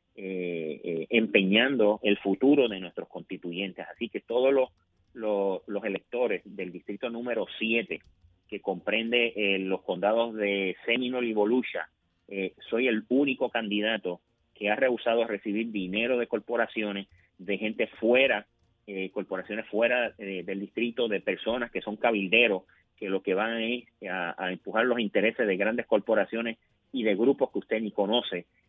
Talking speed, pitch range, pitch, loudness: 155 wpm, 95-115 Hz, 105 Hz, -28 LUFS